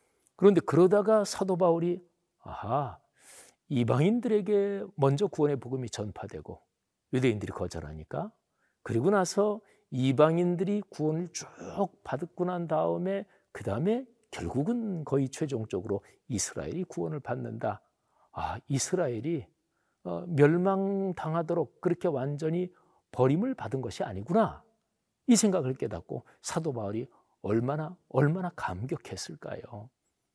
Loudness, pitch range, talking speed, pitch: -30 LUFS, 135-195 Hz, 280 characters per minute, 170 Hz